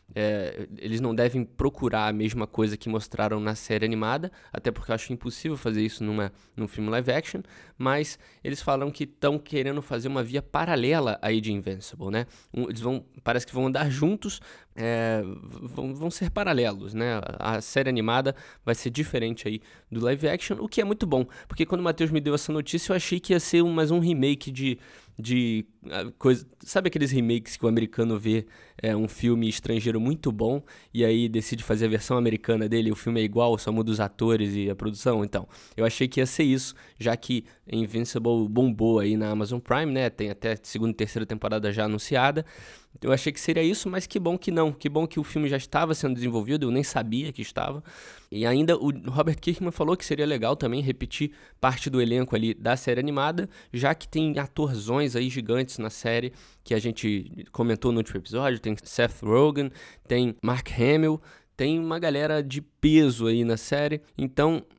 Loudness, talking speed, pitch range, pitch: -27 LUFS, 200 wpm, 110-145 Hz, 125 Hz